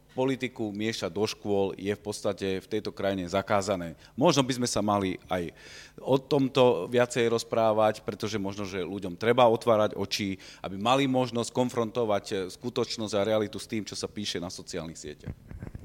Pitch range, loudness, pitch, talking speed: 100-120 Hz, -28 LUFS, 110 Hz, 165 wpm